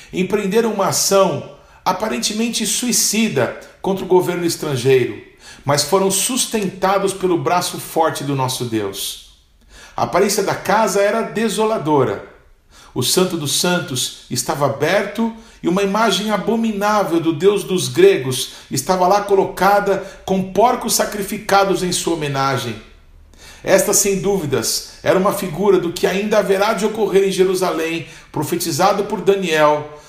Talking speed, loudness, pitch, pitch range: 130 wpm, -17 LUFS, 190 Hz, 160-205 Hz